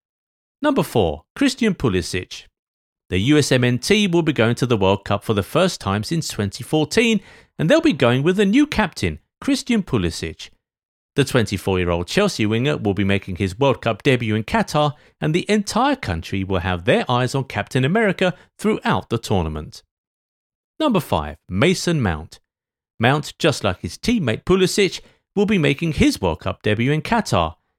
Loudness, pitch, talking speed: -20 LUFS, 130 Hz, 160 wpm